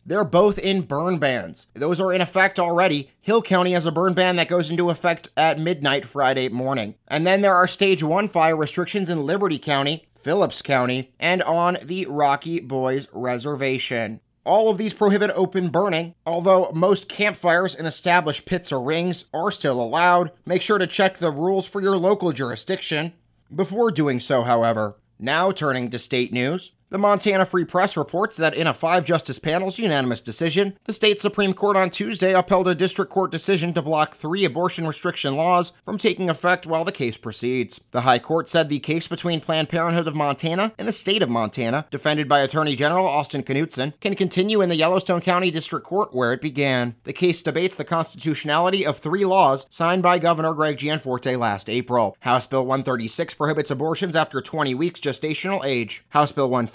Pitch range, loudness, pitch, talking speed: 140-185 Hz, -21 LUFS, 165 Hz, 185 wpm